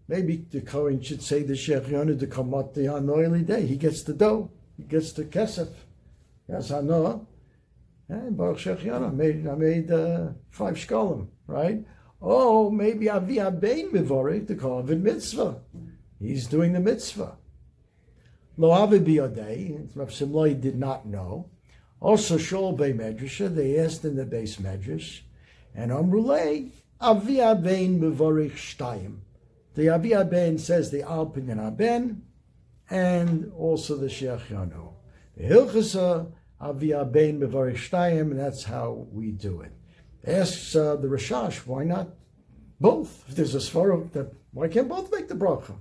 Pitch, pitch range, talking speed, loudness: 155 Hz, 135-180 Hz, 145 wpm, -25 LUFS